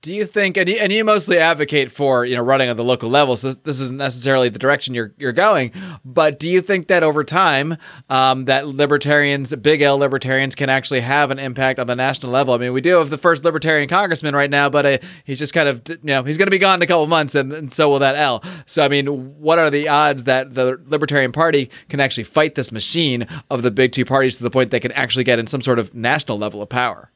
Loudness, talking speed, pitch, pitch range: -17 LUFS, 265 wpm, 140 Hz, 130-155 Hz